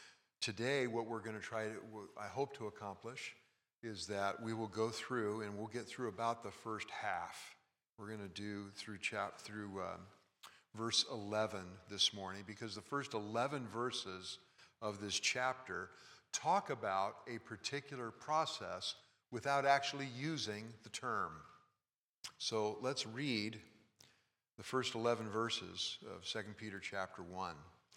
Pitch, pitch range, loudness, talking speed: 110 Hz, 105-120 Hz, -41 LUFS, 145 wpm